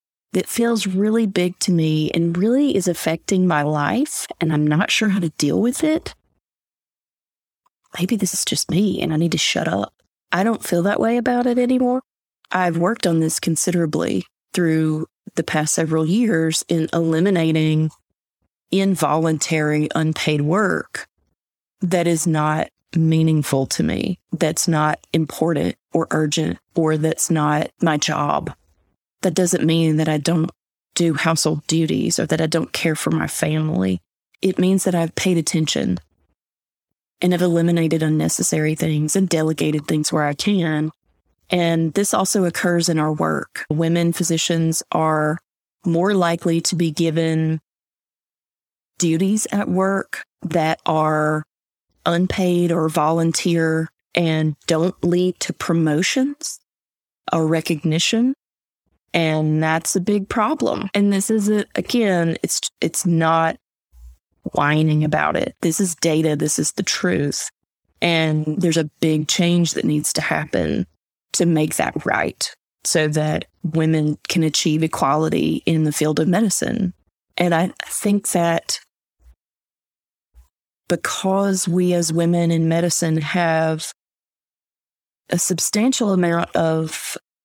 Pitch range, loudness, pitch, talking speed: 155-185 Hz, -19 LUFS, 165 Hz, 135 wpm